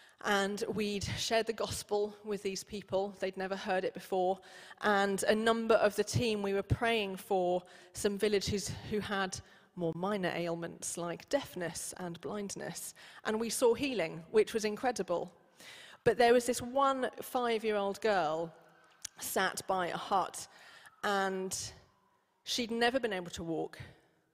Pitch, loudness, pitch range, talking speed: 200 Hz, -34 LUFS, 185-225 Hz, 150 wpm